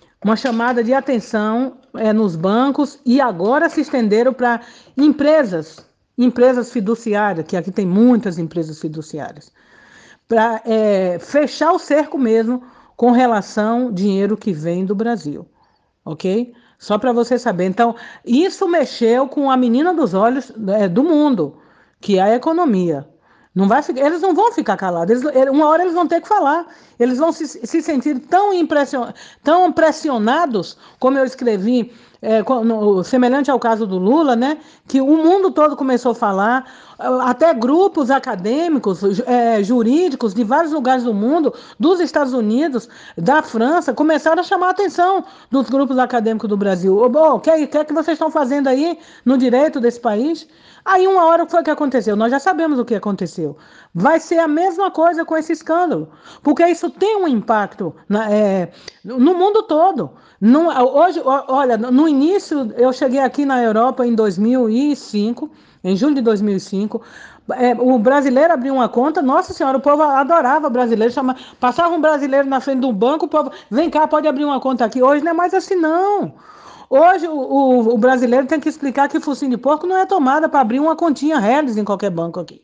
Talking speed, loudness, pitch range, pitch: 180 wpm, -16 LUFS, 230-310 Hz, 260 Hz